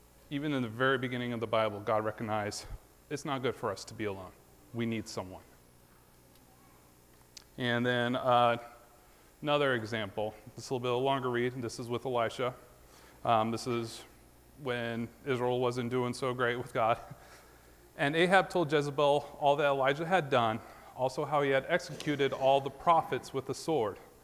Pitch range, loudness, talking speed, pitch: 105-135 Hz, -32 LUFS, 175 wpm, 120 Hz